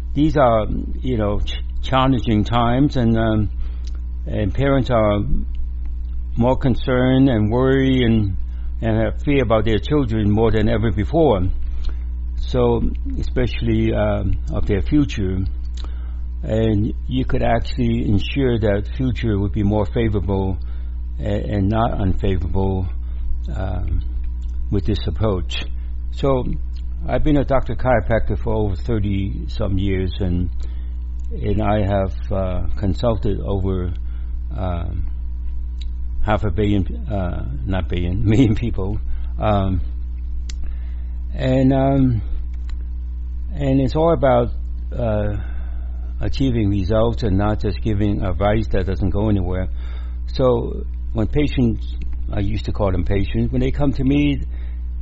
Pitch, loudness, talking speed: 95 Hz, -21 LUFS, 120 wpm